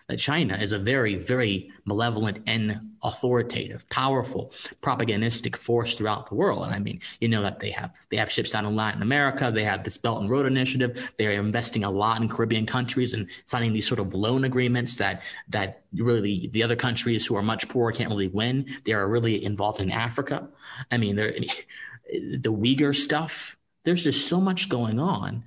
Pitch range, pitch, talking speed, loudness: 105-125 Hz, 115 Hz, 190 wpm, -26 LUFS